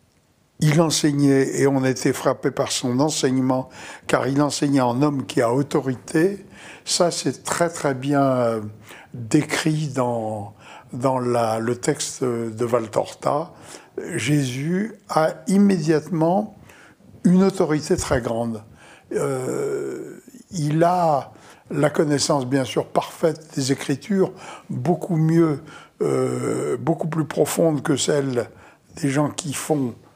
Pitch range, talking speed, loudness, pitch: 130-165 Hz, 115 wpm, -21 LUFS, 145 Hz